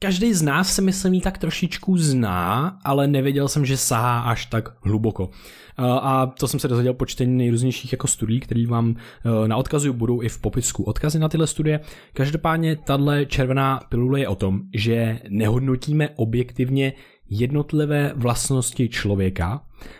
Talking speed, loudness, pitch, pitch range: 155 wpm, -21 LUFS, 130 Hz, 115-145 Hz